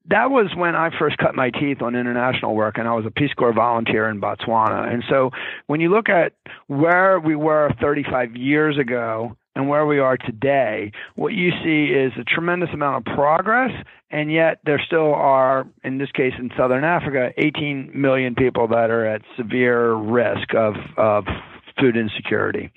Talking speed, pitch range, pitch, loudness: 180 wpm, 120-150 Hz, 130 Hz, -19 LUFS